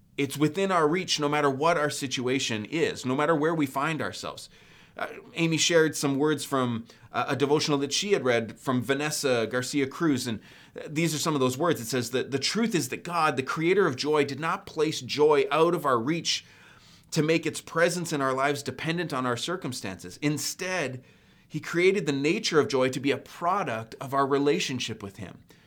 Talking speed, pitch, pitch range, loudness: 205 wpm, 145 Hz, 130-160 Hz, -26 LUFS